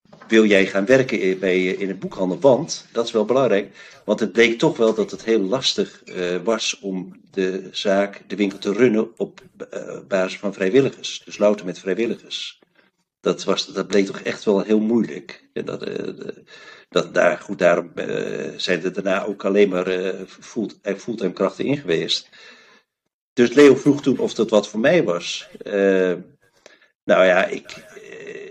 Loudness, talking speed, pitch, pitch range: -20 LUFS, 175 wpm, 100 Hz, 95-115 Hz